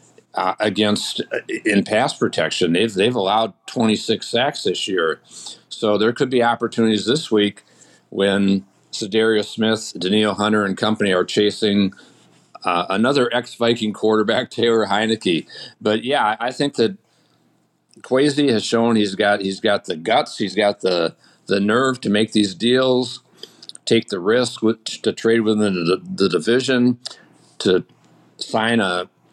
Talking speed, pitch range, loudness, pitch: 145 wpm, 105-120 Hz, -19 LUFS, 110 Hz